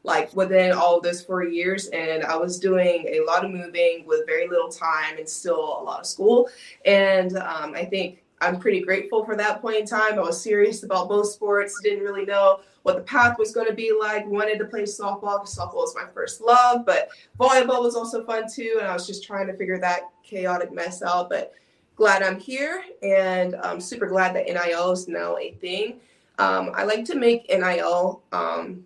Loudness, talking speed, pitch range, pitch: -23 LUFS, 215 wpm, 185-235 Hz, 200 Hz